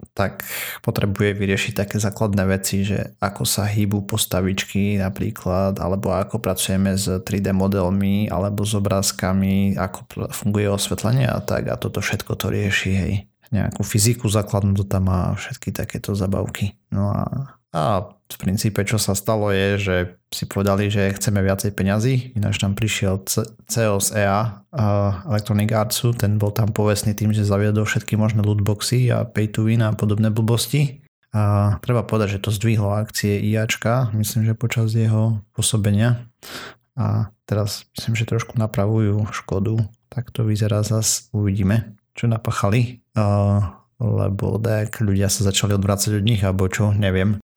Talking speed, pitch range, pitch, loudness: 155 wpm, 100-110 Hz, 105 Hz, -21 LUFS